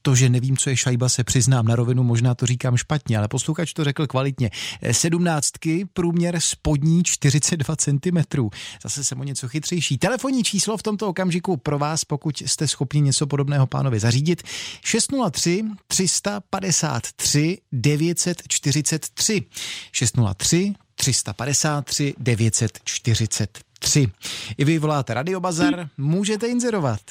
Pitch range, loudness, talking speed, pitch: 125-170 Hz, -21 LUFS, 125 wpm, 145 Hz